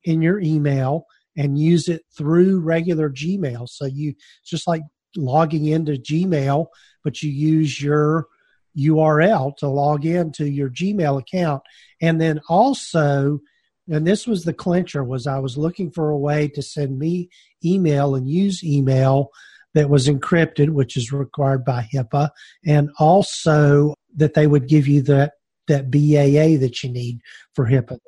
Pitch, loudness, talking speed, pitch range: 150 Hz, -19 LUFS, 155 wpm, 140-165 Hz